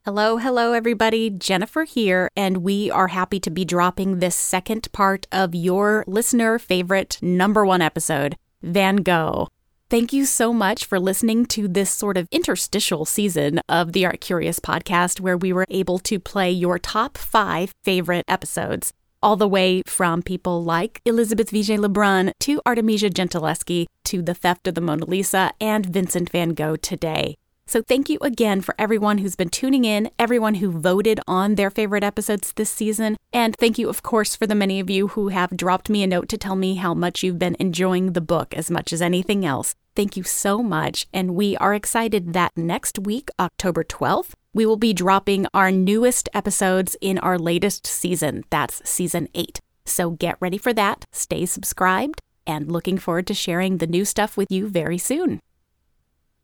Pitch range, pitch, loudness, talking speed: 180-215 Hz, 190 Hz, -21 LUFS, 185 wpm